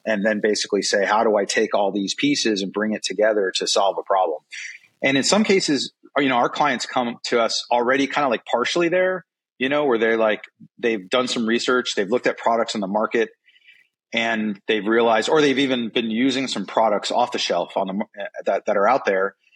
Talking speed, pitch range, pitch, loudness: 220 wpm, 110-140 Hz, 120 Hz, -21 LUFS